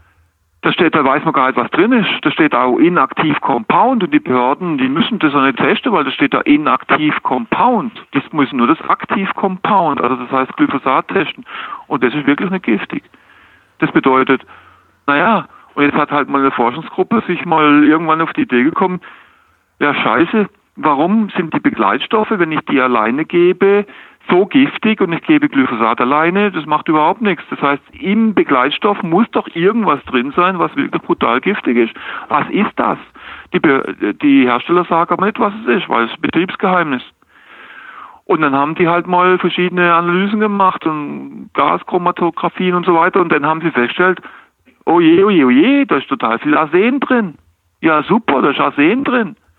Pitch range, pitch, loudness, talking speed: 145-215 Hz, 180 Hz, -14 LUFS, 185 wpm